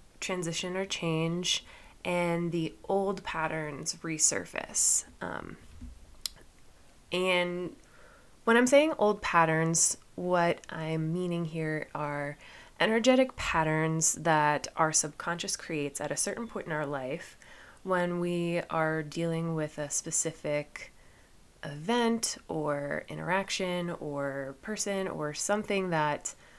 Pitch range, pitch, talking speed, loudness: 150-180 Hz, 165 Hz, 110 wpm, -30 LUFS